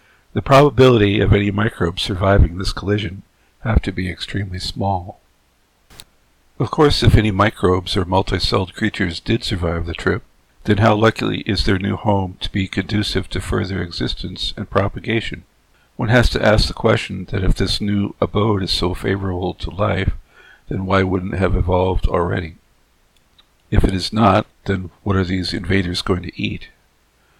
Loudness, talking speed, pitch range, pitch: -18 LUFS, 165 wpm, 90-105 Hz, 95 Hz